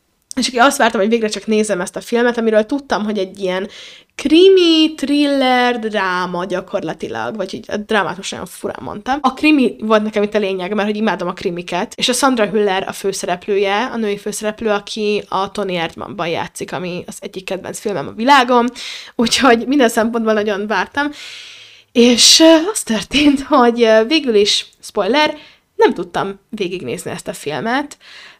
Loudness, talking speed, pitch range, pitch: -15 LUFS, 160 wpm, 200-250 Hz, 220 Hz